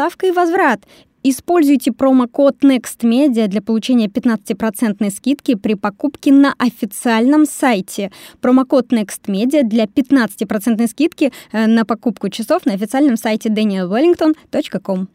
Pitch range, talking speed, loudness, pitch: 220-285 Hz, 105 wpm, -15 LUFS, 245 Hz